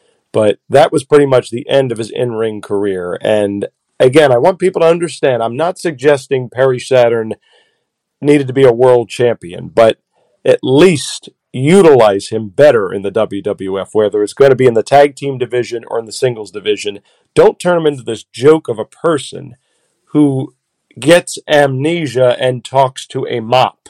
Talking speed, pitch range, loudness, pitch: 180 wpm, 115-150 Hz, -12 LUFS, 130 Hz